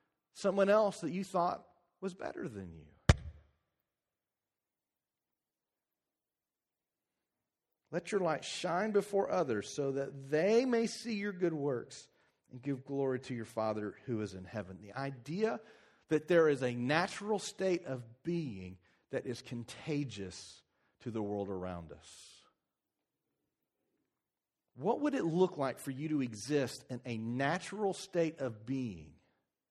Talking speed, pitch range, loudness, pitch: 135 wpm, 110-180 Hz, -36 LUFS, 135 Hz